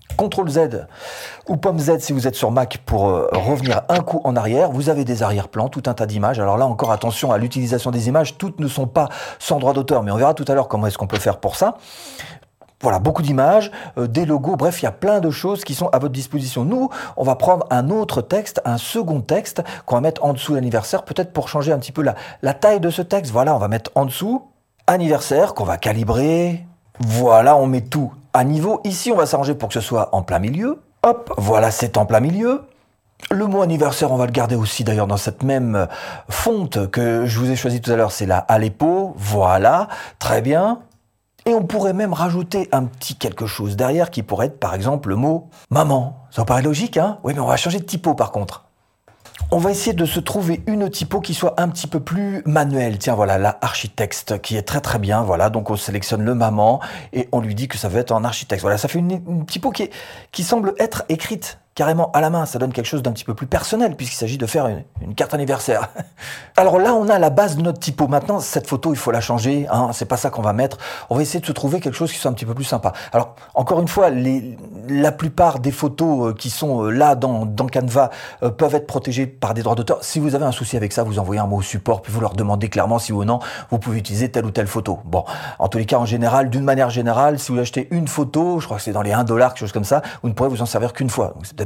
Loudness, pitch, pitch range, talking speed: -19 LUFS, 135 Hz, 115-160 Hz, 255 wpm